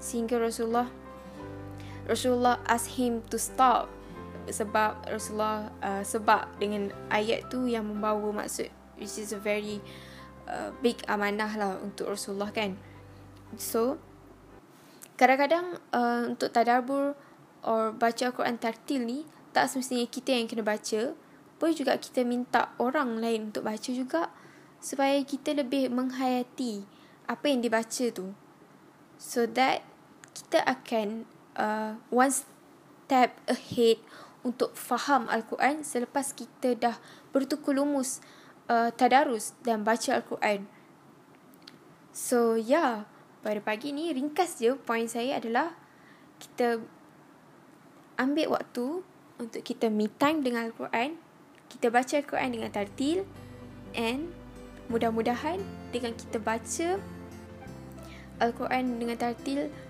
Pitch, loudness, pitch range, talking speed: 235 Hz, -29 LUFS, 215-260 Hz, 115 wpm